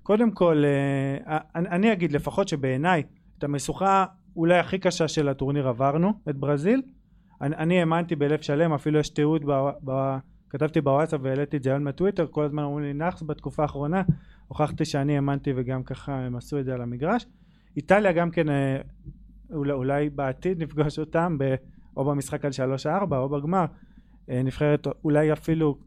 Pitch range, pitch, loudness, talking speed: 140-175 Hz, 150 Hz, -25 LUFS, 150 wpm